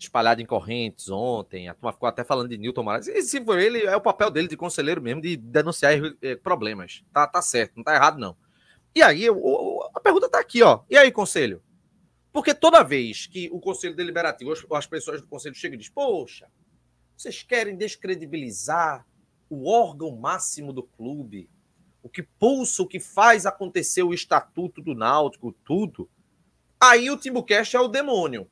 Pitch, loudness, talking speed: 175 Hz, -22 LUFS, 180 wpm